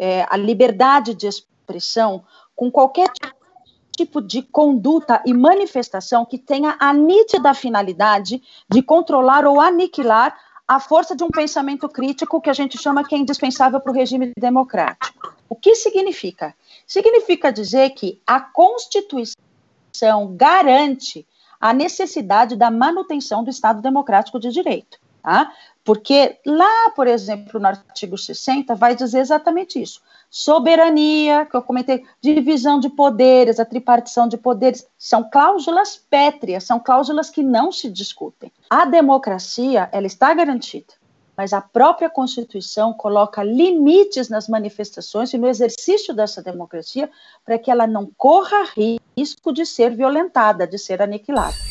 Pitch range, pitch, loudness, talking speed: 225-305 Hz, 260 Hz, -16 LUFS, 135 wpm